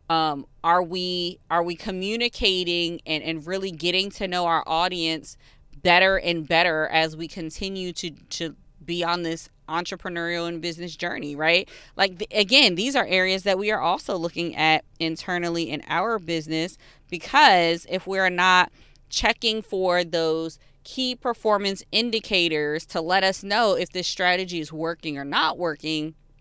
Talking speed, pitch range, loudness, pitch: 155 wpm, 165-190 Hz, -23 LUFS, 175 Hz